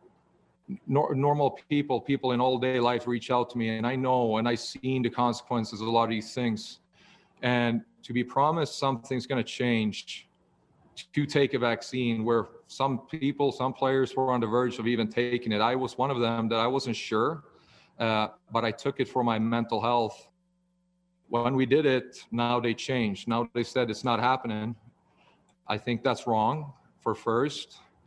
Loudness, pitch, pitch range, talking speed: -28 LUFS, 120 Hz, 115-130 Hz, 185 wpm